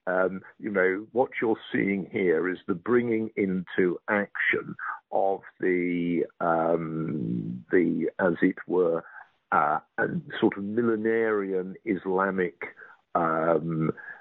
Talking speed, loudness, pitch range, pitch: 110 wpm, -27 LUFS, 85-105 Hz, 95 Hz